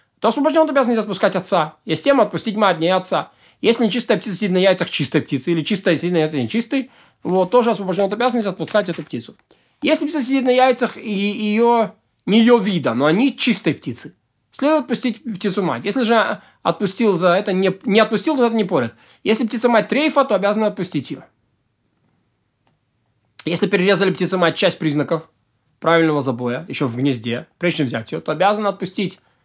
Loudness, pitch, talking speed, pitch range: -18 LUFS, 200 Hz, 185 wpm, 165-230 Hz